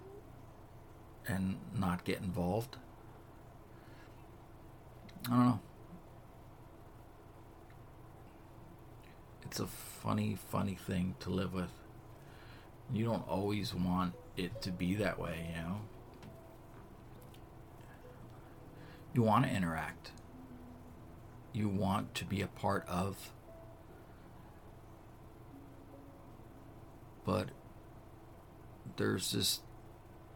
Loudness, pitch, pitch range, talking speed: -37 LUFS, 110 Hz, 95-115 Hz, 80 wpm